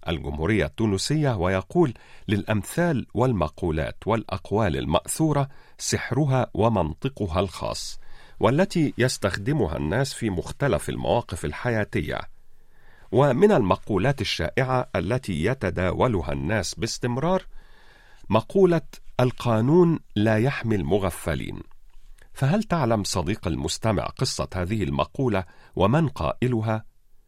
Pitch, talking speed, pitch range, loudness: 110 Hz, 85 wpm, 95-135 Hz, -24 LUFS